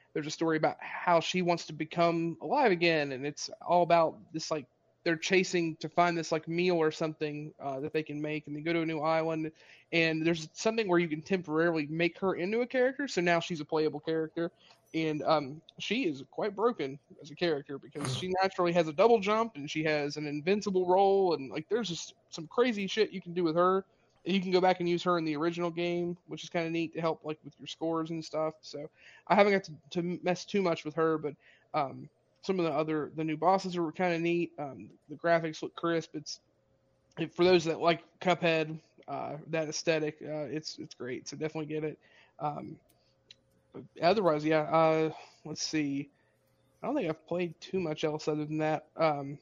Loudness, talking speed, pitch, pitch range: -31 LUFS, 220 wpm, 165 Hz, 155-175 Hz